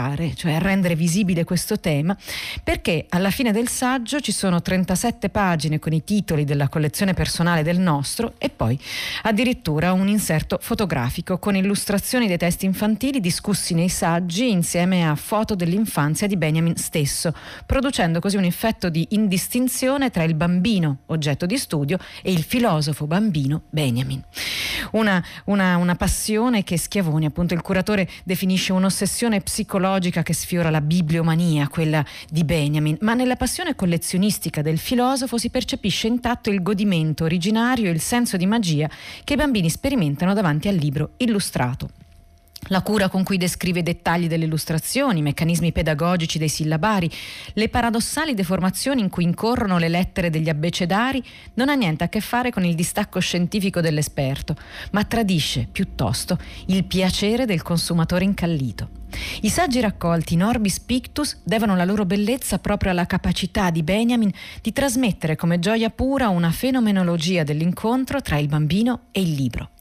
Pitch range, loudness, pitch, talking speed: 165-215 Hz, -21 LUFS, 185 Hz, 150 wpm